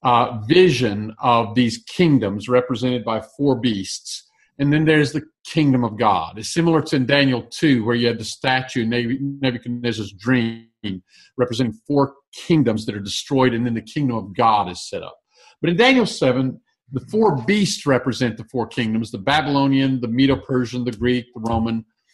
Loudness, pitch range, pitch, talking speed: -20 LUFS, 115-140 Hz, 125 Hz, 175 wpm